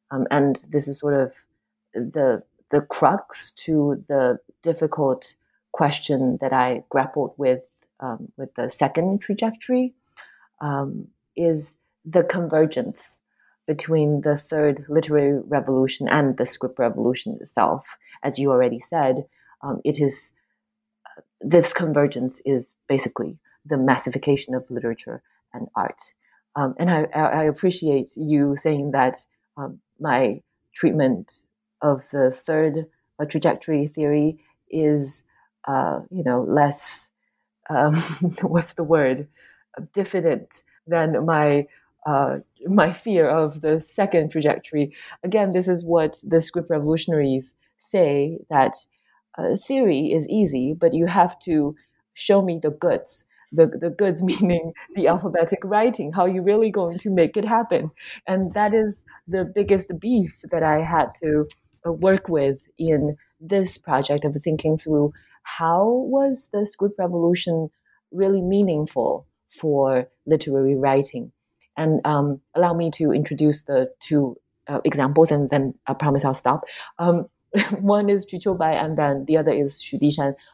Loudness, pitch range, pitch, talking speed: -22 LUFS, 140-180 Hz, 155 Hz, 135 wpm